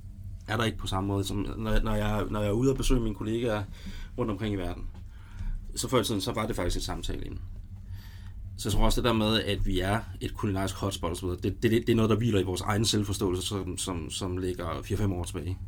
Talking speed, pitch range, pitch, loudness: 250 wpm, 95-110 Hz, 100 Hz, -29 LUFS